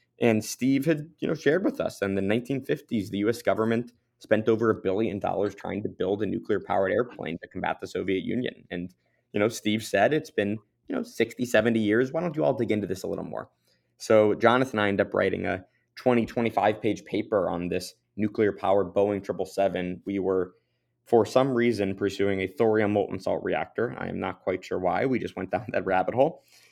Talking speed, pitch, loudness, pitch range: 205 wpm, 110 Hz, -27 LUFS, 100-120 Hz